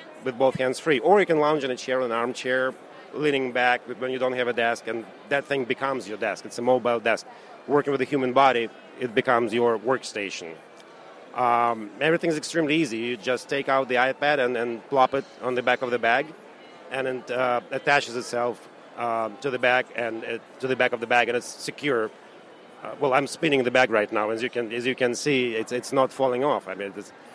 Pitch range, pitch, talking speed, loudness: 120-135 Hz, 125 Hz, 230 wpm, -24 LUFS